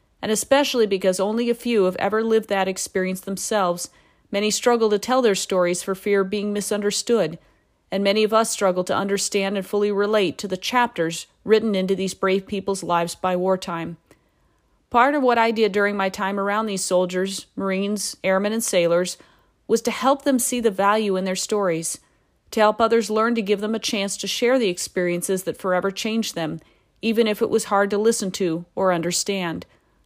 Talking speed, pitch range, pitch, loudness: 190 wpm, 185-220 Hz, 200 Hz, -21 LUFS